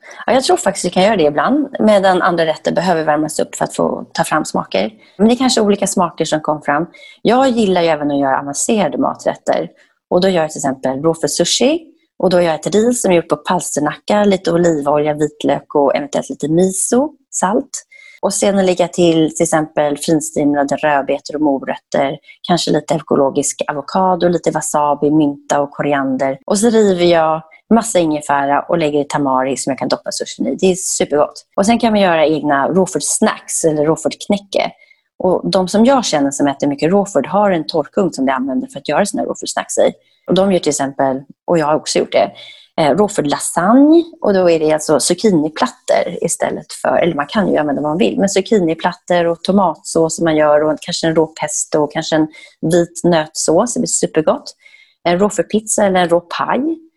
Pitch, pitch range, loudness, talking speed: 170 Hz, 150-200 Hz, -15 LUFS, 200 wpm